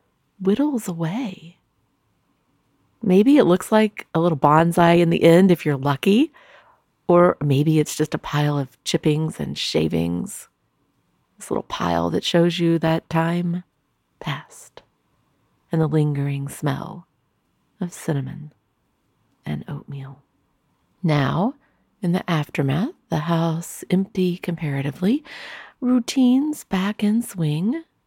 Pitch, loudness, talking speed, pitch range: 165 Hz, -21 LUFS, 115 wpm, 145-190 Hz